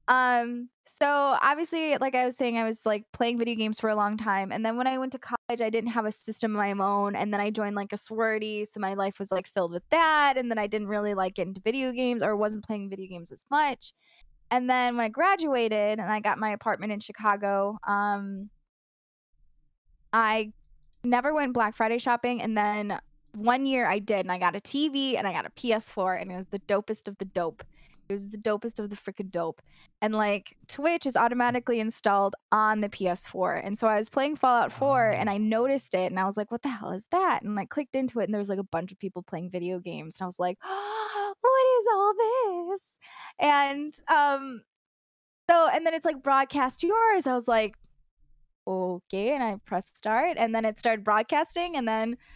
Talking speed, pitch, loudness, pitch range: 225 wpm, 220 Hz, -27 LUFS, 200-260 Hz